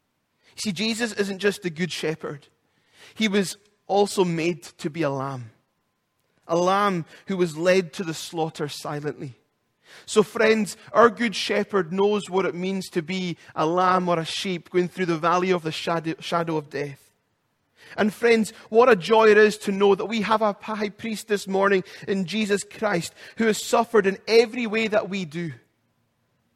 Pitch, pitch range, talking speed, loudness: 190 Hz, 165-210 Hz, 175 wpm, -23 LUFS